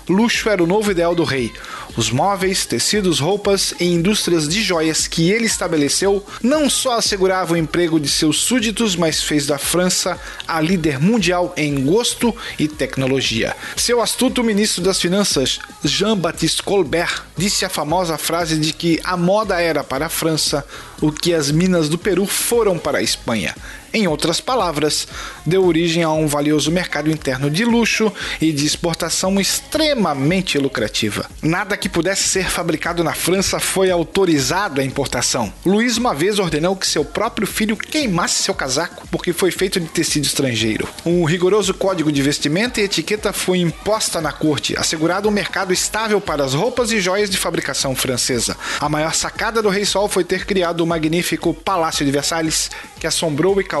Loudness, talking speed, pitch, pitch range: -17 LUFS, 170 wpm, 175 Hz, 155-195 Hz